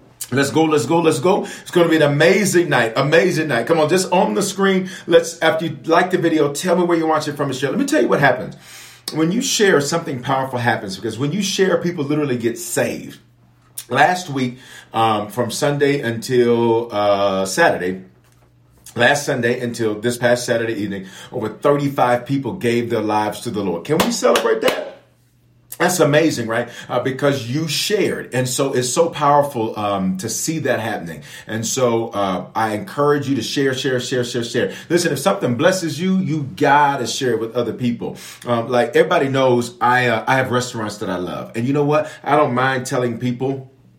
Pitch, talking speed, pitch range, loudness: 130 Hz, 200 wpm, 115-155 Hz, -18 LUFS